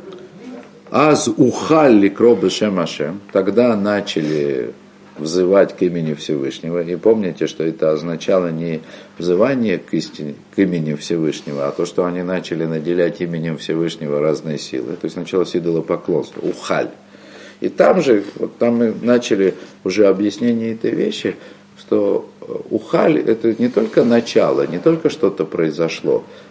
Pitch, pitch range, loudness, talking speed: 90 Hz, 80-115 Hz, -17 LUFS, 135 wpm